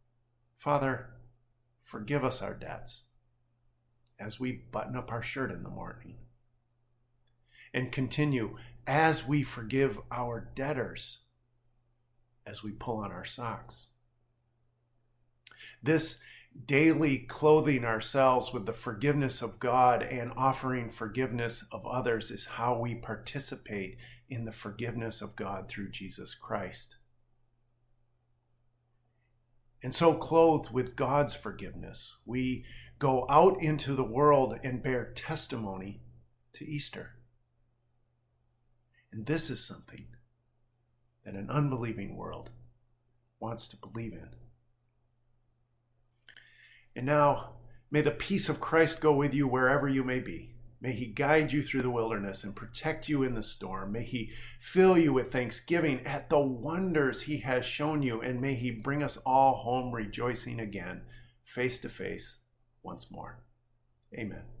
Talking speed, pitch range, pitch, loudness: 125 wpm, 120-130 Hz, 120 Hz, -31 LUFS